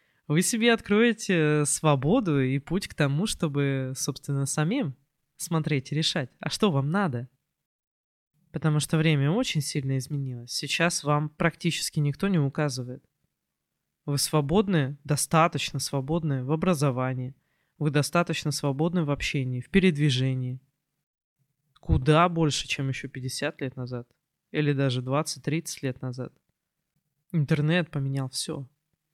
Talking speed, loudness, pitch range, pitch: 120 wpm, -26 LUFS, 135-160 Hz, 150 Hz